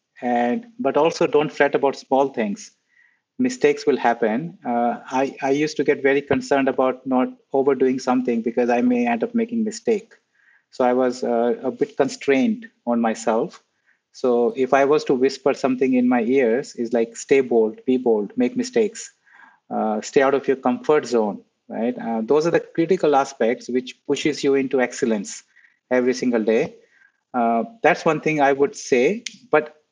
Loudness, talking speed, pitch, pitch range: -21 LUFS, 175 wpm, 135 Hz, 125-165 Hz